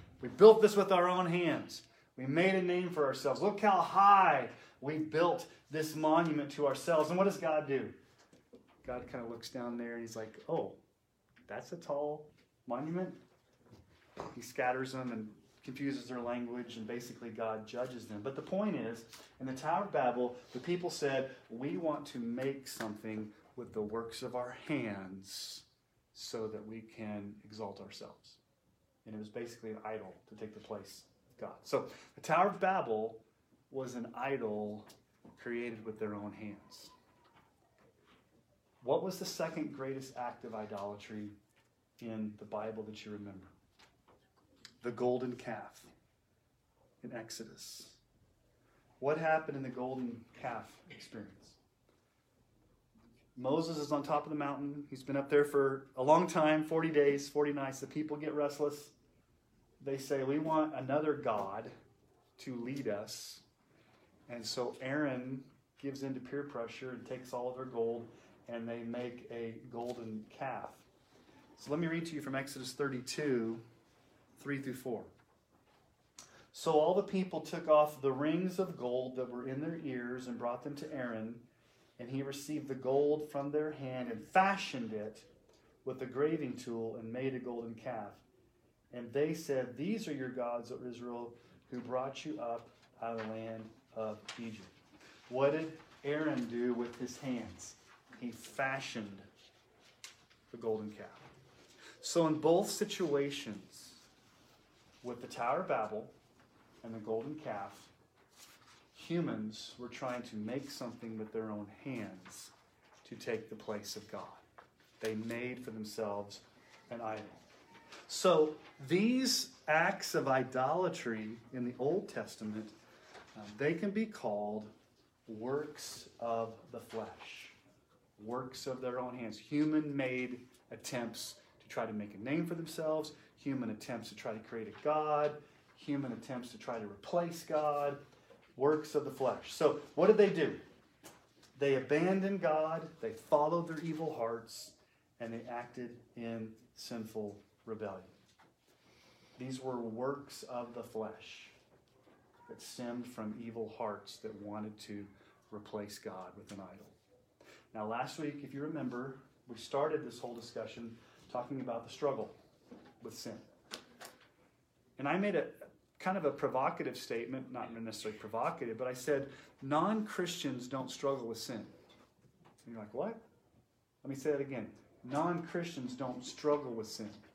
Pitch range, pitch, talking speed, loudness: 115-145 Hz, 125 Hz, 150 wpm, -37 LUFS